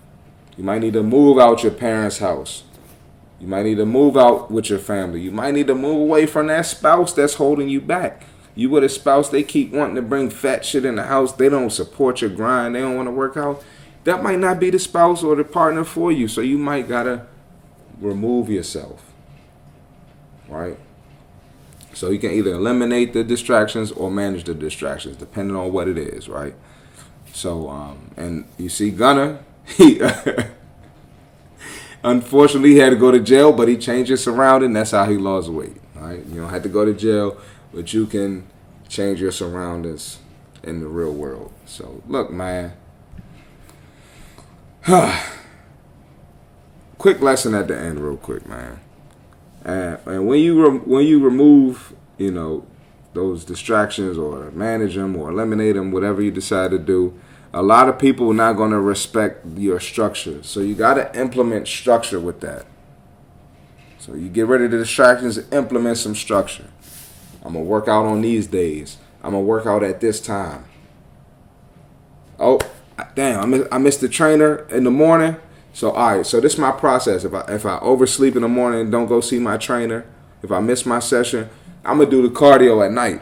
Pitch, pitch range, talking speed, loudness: 115 Hz, 100-135 Hz, 190 wpm, -17 LUFS